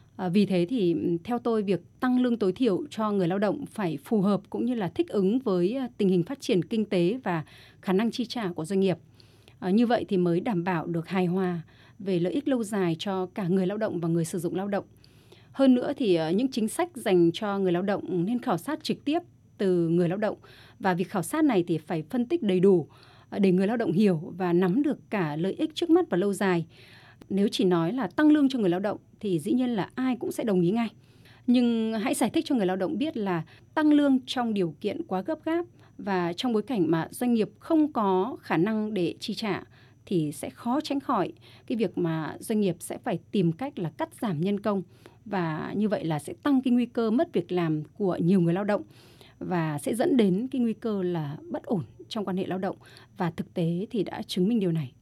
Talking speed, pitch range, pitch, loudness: 240 wpm, 170-235 Hz, 190 Hz, -27 LUFS